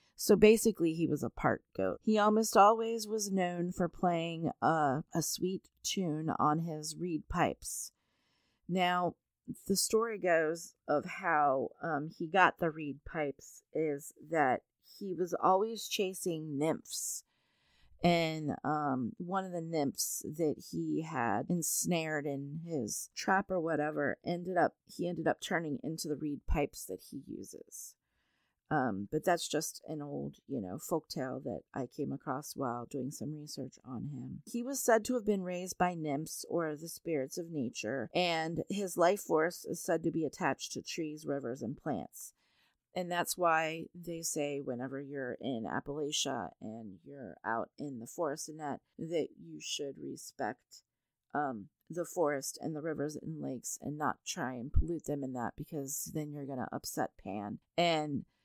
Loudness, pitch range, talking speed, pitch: -35 LUFS, 145-180 Hz, 165 wpm, 160 Hz